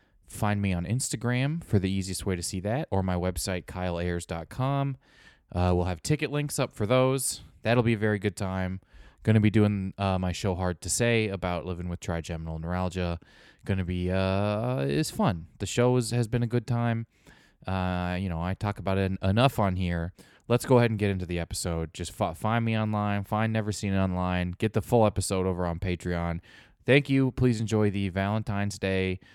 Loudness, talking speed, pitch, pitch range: -28 LUFS, 200 wpm, 95 Hz, 90-110 Hz